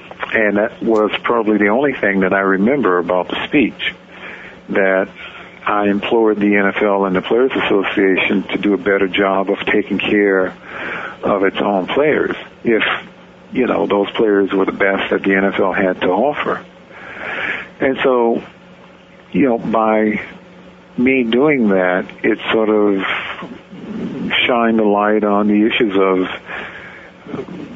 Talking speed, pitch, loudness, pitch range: 145 wpm, 100 Hz, -16 LUFS, 95-110 Hz